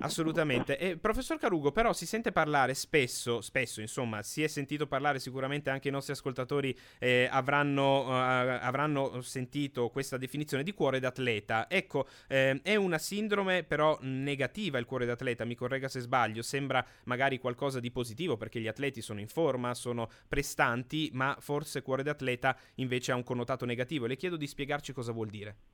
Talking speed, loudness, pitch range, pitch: 170 wpm, -32 LUFS, 125-145 Hz, 135 Hz